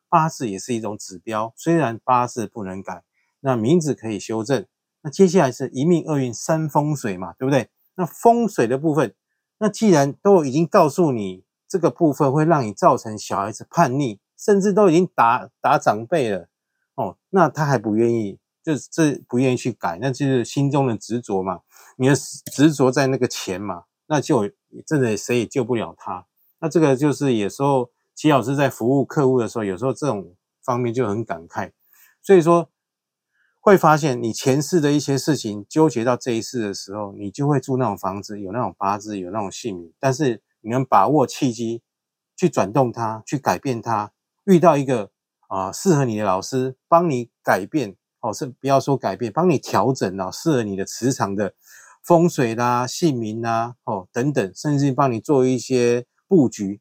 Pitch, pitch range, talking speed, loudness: 130 Hz, 110-150 Hz, 275 characters per minute, -20 LUFS